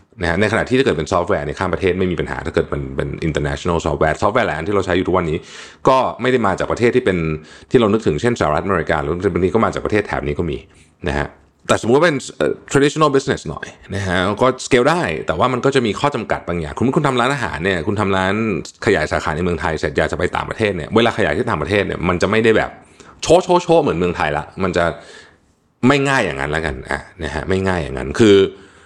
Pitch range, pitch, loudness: 80-110 Hz, 90 Hz, -17 LUFS